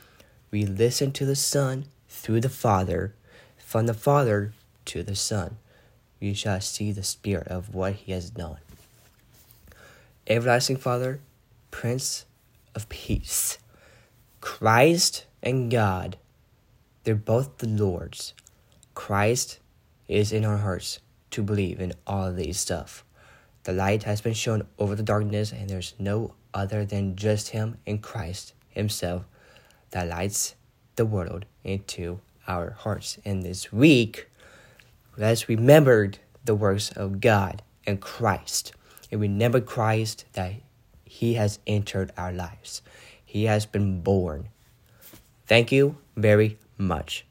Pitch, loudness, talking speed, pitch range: 105 Hz, -25 LUFS, 130 wpm, 100-115 Hz